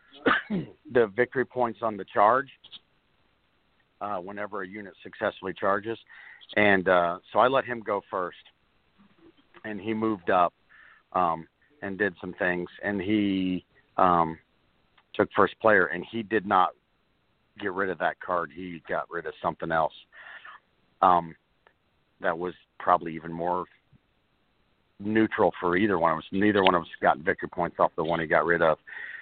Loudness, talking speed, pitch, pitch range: -26 LUFS, 155 wpm, 95 Hz, 85-110 Hz